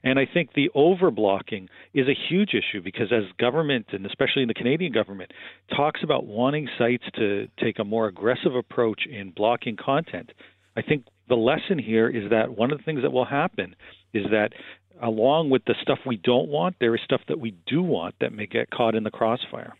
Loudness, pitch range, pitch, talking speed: -24 LUFS, 110-140 Hz, 120 Hz, 205 wpm